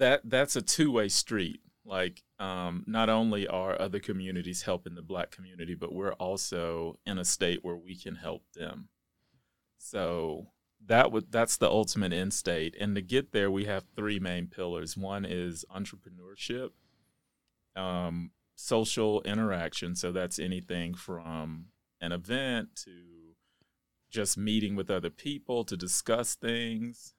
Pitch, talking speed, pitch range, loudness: 95 Hz, 145 wpm, 90-110 Hz, -32 LUFS